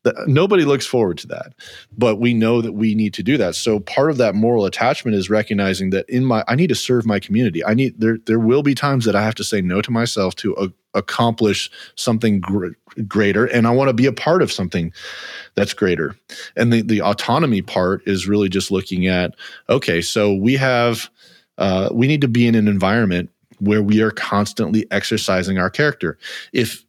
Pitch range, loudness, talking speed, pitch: 95-120 Hz, -18 LUFS, 210 wpm, 110 Hz